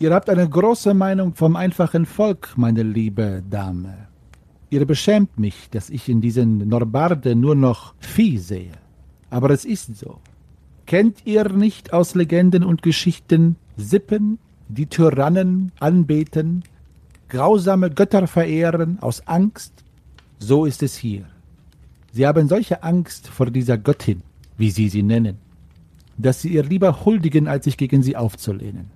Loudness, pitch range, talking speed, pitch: -18 LUFS, 110-180 Hz, 140 wpm, 145 Hz